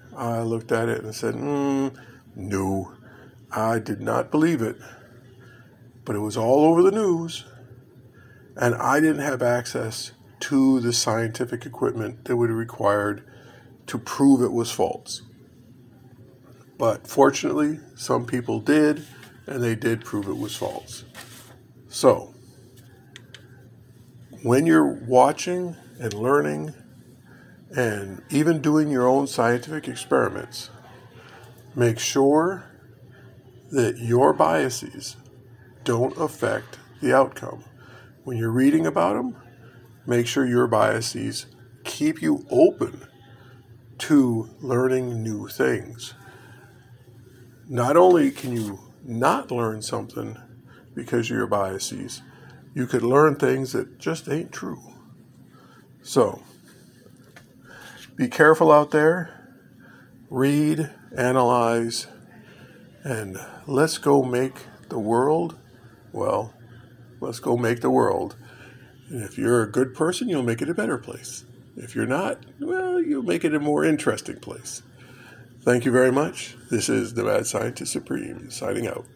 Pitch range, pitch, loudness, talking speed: 120-135 Hz, 125 Hz, -23 LUFS, 120 wpm